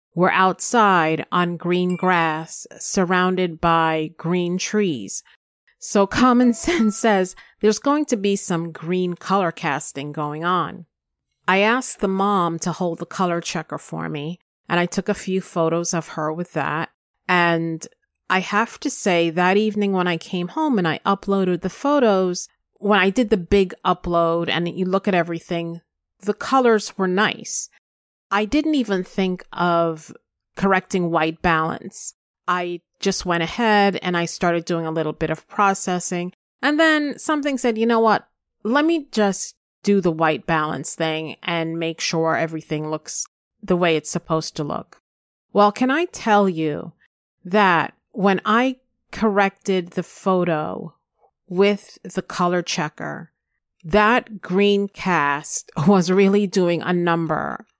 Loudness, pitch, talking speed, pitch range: -20 LUFS, 185 Hz, 150 wpm, 170-205 Hz